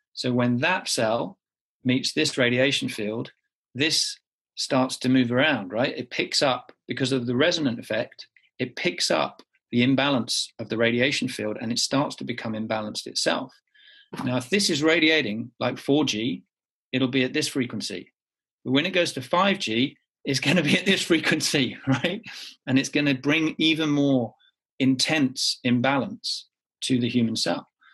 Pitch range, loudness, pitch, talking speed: 125-155 Hz, -24 LUFS, 130 Hz, 165 wpm